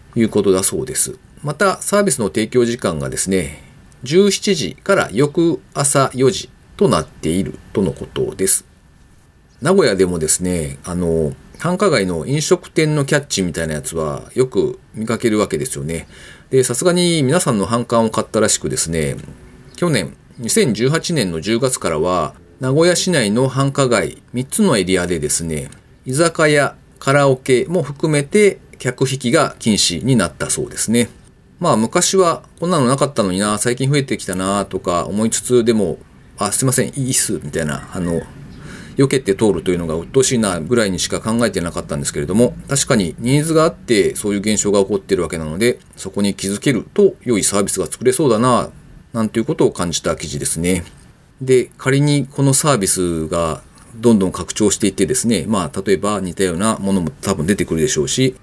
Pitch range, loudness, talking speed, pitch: 95-145 Hz, -17 LUFS, 365 characters per minute, 120 Hz